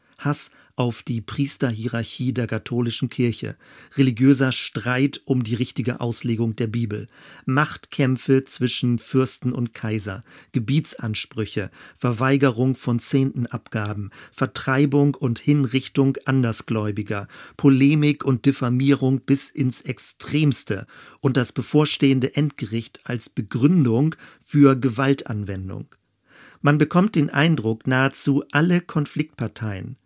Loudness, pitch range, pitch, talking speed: -21 LUFS, 120-140 Hz, 130 Hz, 100 wpm